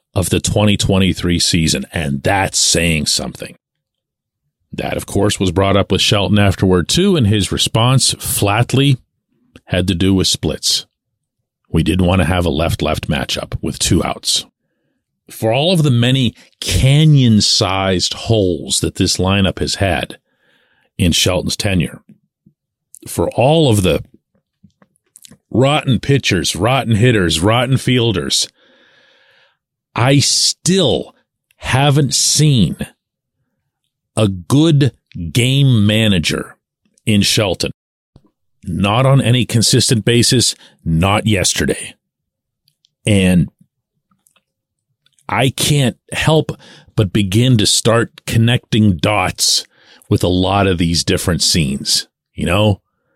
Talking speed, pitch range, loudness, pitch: 115 wpm, 95-130 Hz, -14 LUFS, 110 Hz